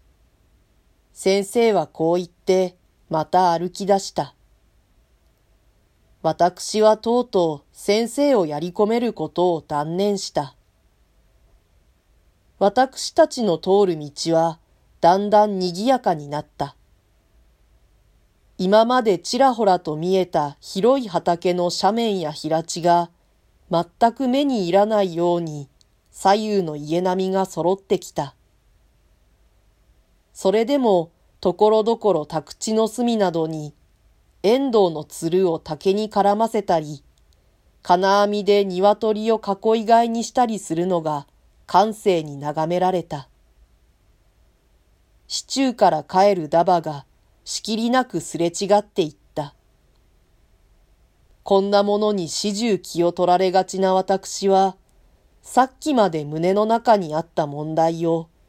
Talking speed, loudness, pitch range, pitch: 215 characters per minute, -20 LUFS, 150-205 Hz, 180 Hz